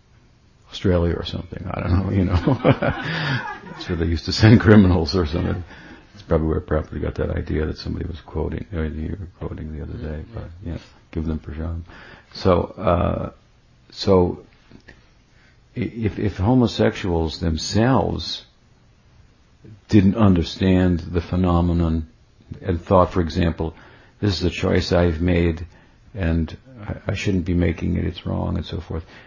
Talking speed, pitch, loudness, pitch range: 150 wpm, 90 Hz, -21 LUFS, 80-100 Hz